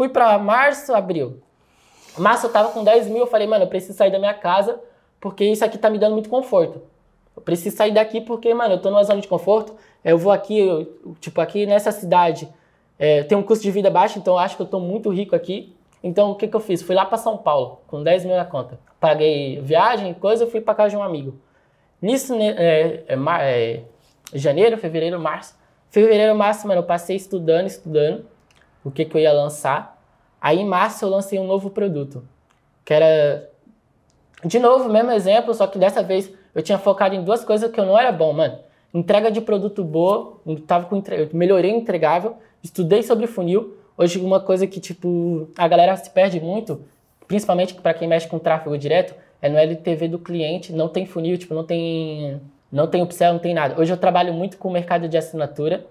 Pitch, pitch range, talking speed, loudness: 185 Hz, 165-210 Hz, 210 wpm, -19 LUFS